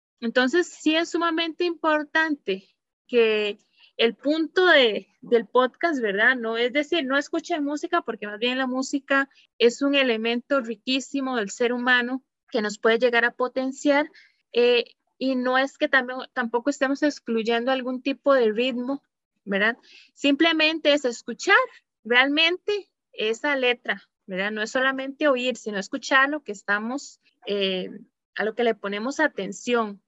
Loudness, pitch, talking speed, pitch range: -23 LUFS, 260 Hz, 145 wpm, 230-295 Hz